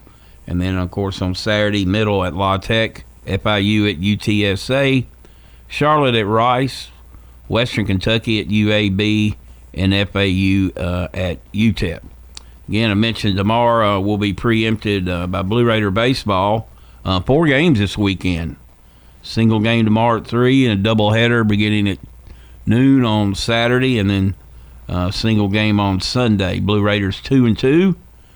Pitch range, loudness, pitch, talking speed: 90-110 Hz, -17 LUFS, 105 Hz, 145 wpm